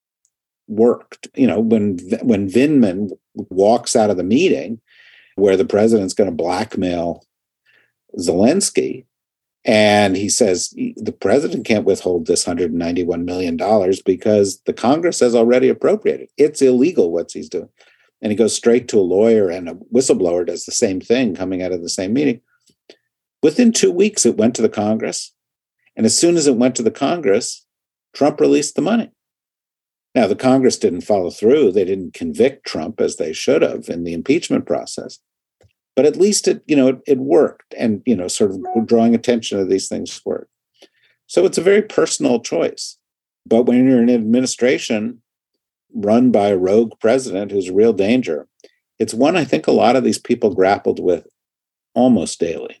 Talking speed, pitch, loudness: 175 wpm, 125 Hz, -16 LUFS